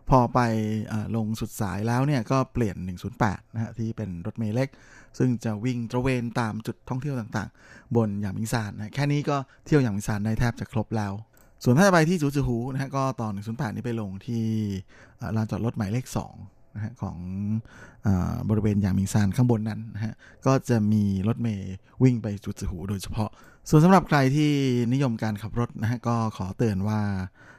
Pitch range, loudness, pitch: 105-125 Hz, -26 LUFS, 115 Hz